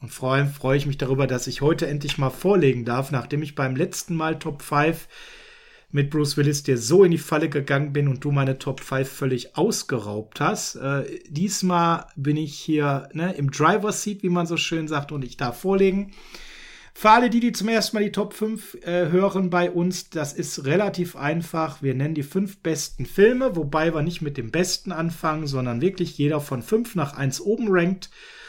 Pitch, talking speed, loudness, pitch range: 160 Hz, 205 wpm, -23 LUFS, 140-185 Hz